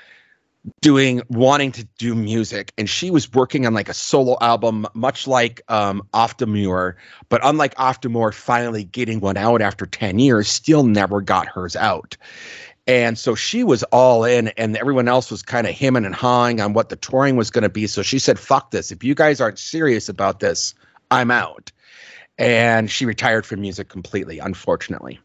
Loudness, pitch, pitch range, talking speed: -18 LUFS, 115 Hz, 105-130 Hz, 180 wpm